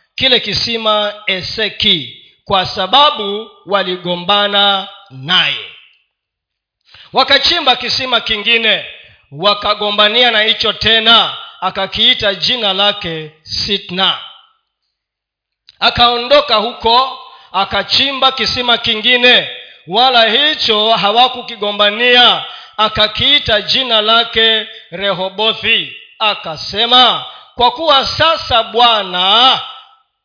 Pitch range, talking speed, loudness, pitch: 200-245 Hz, 70 wpm, -11 LUFS, 220 Hz